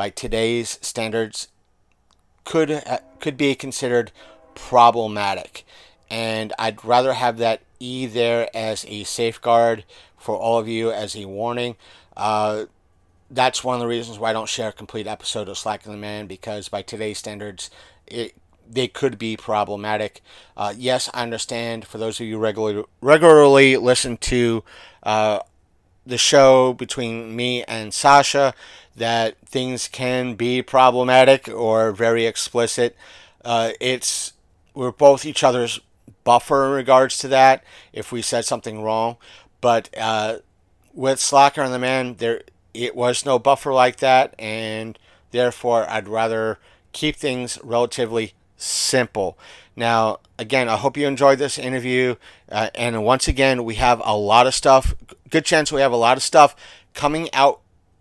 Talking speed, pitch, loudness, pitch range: 150 wpm, 115 Hz, -19 LUFS, 110-130 Hz